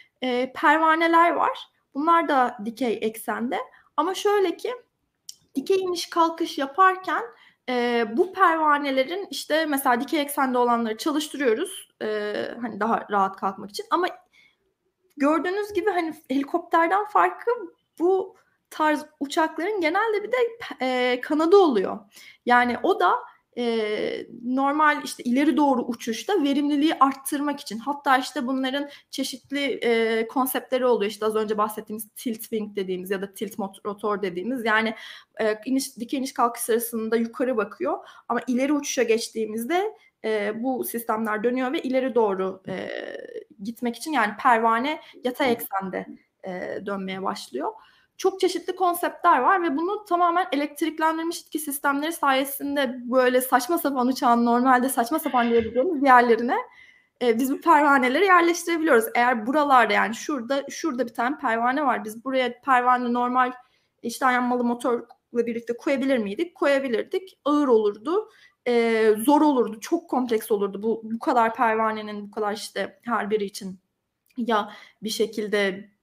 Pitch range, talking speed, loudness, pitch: 230-325 Hz, 135 wpm, -23 LUFS, 260 Hz